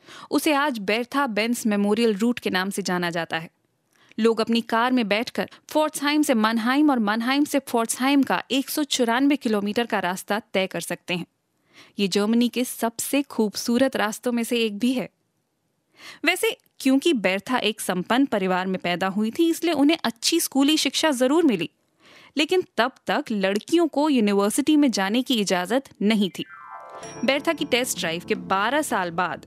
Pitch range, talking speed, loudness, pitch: 205-275 Hz, 165 wpm, -23 LUFS, 235 Hz